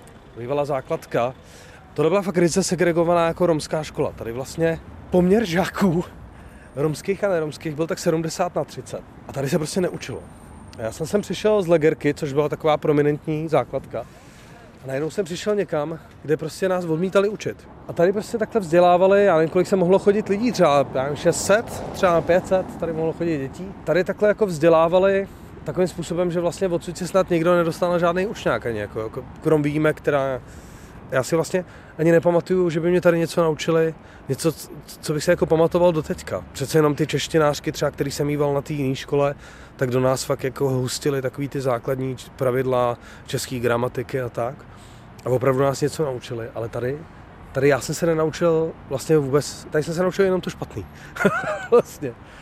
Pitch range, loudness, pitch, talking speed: 135-175 Hz, -22 LUFS, 160 Hz, 180 wpm